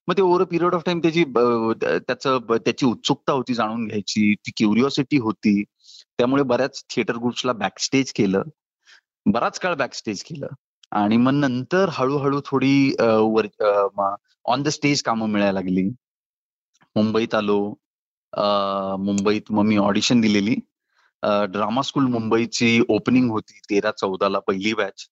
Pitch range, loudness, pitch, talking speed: 105-135 Hz, -21 LUFS, 115 Hz, 130 wpm